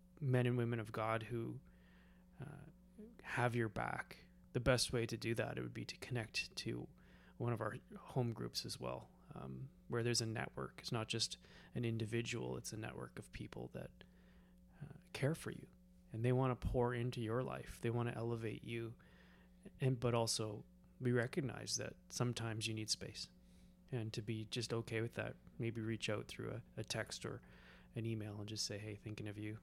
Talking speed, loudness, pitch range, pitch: 195 wpm, -42 LUFS, 105-120 Hz, 115 Hz